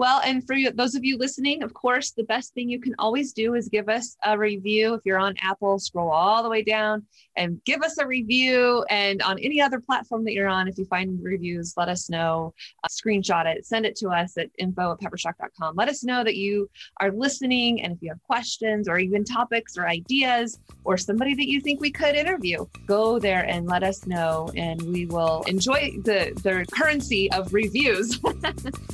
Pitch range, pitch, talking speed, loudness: 185-250 Hz, 215 Hz, 210 wpm, -24 LUFS